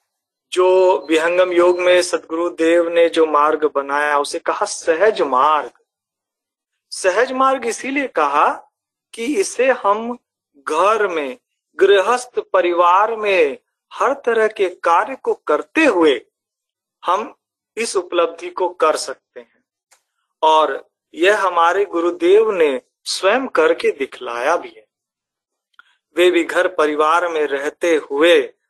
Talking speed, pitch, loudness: 115 wpm, 205 Hz, -17 LUFS